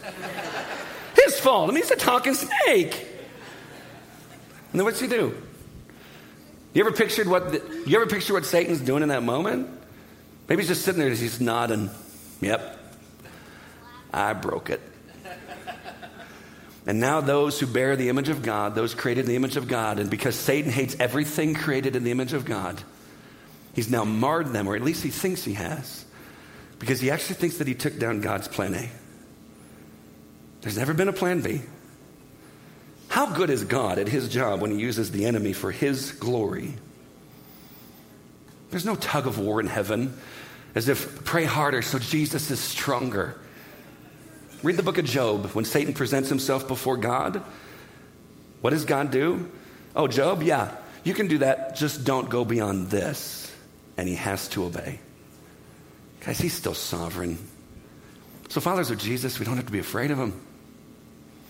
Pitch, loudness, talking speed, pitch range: 125 Hz, -25 LUFS, 170 wpm, 105-145 Hz